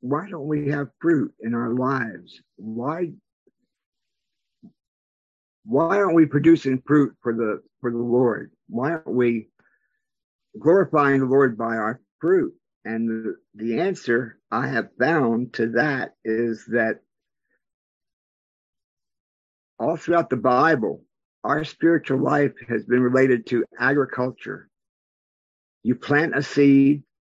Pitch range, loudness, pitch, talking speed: 115-145 Hz, -22 LUFS, 130 Hz, 120 wpm